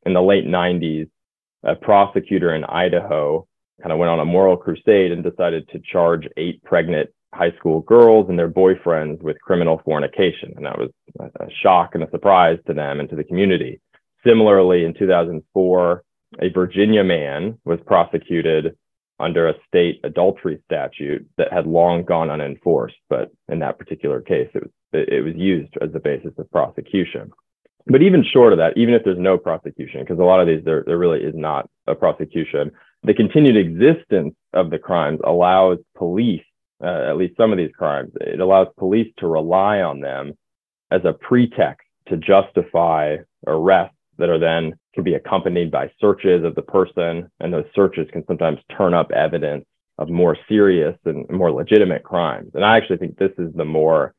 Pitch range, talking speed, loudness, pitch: 85-100 Hz, 175 wpm, -18 LUFS, 90 Hz